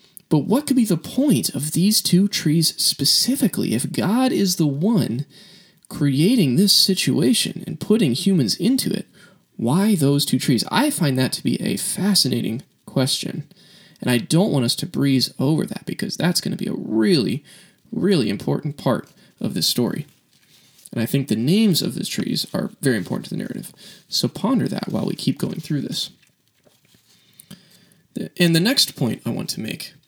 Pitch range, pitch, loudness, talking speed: 145-205 Hz, 185 Hz, -20 LUFS, 180 wpm